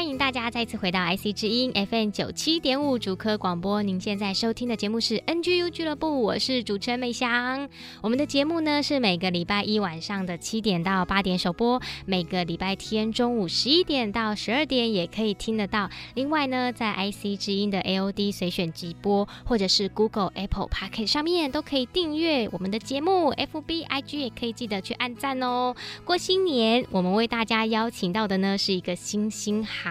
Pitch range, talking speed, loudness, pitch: 200-260 Hz, 335 characters per minute, -26 LUFS, 220 Hz